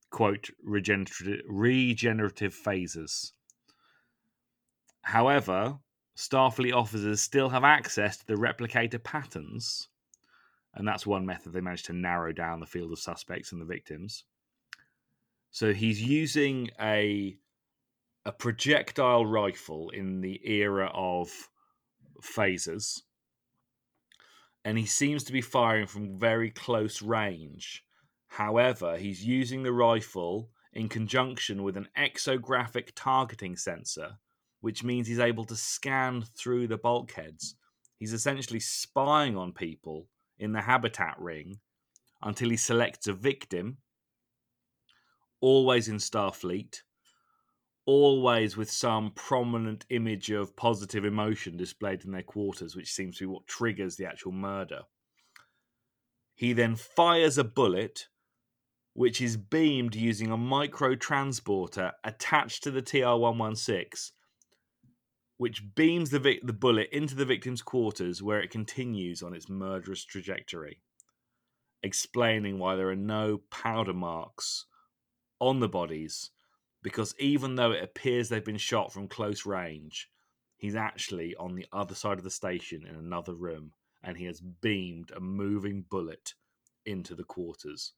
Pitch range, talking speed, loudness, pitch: 95-125 Hz, 130 wpm, -30 LUFS, 110 Hz